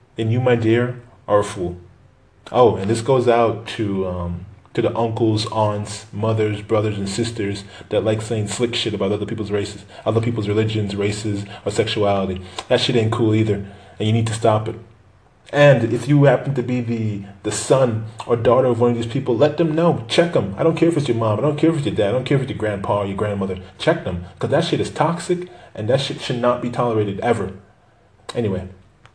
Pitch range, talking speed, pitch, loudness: 100-120 Hz, 225 wpm, 110 Hz, -20 LUFS